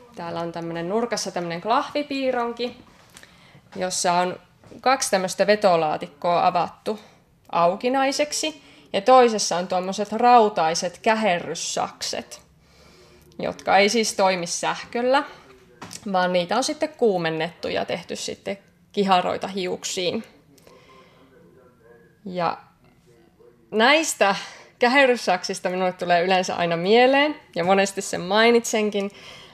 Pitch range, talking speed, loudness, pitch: 180-245 Hz, 95 wpm, -22 LUFS, 200 Hz